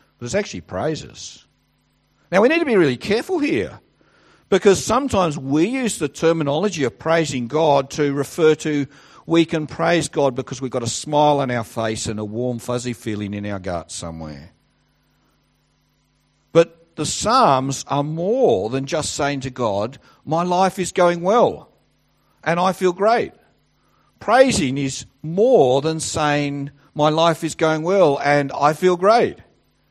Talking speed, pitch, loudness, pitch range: 155 wpm, 150 Hz, -19 LUFS, 135-170 Hz